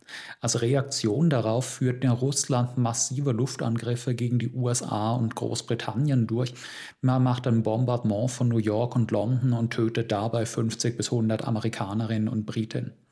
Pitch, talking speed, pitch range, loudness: 120 Hz, 145 wpm, 115-125 Hz, -26 LUFS